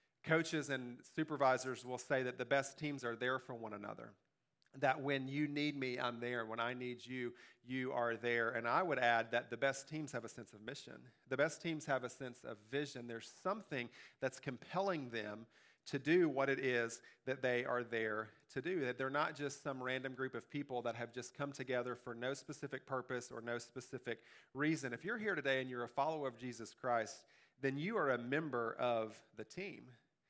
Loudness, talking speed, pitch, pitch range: -41 LUFS, 210 wpm, 130 Hz, 120-140 Hz